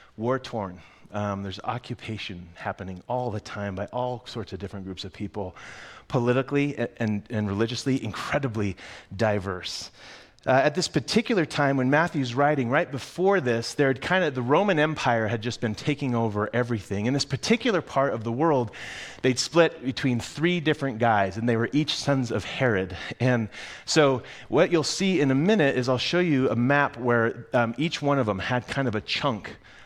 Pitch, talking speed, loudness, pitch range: 125 Hz, 180 wpm, -25 LUFS, 110-140 Hz